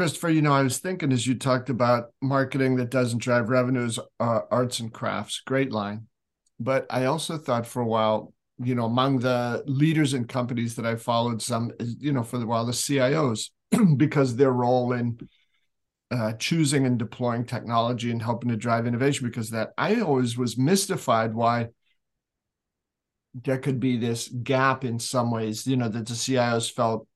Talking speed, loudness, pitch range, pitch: 180 wpm, -25 LUFS, 115-135 Hz, 125 Hz